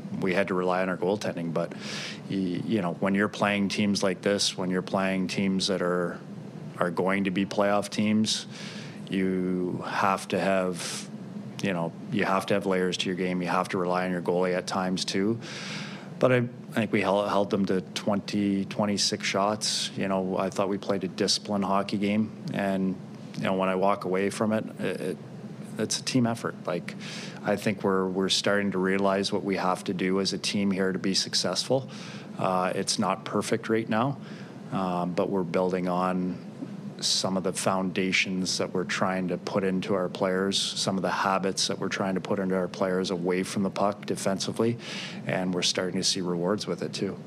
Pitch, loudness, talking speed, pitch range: 95 Hz, -27 LUFS, 200 wpm, 95-100 Hz